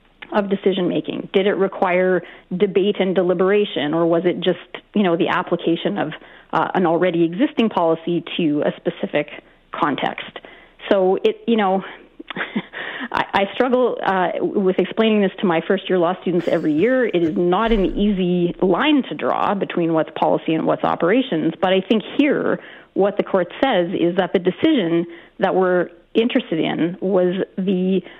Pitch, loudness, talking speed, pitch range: 185 Hz, -19 LUFS, 165 wpm, 175-200 Hz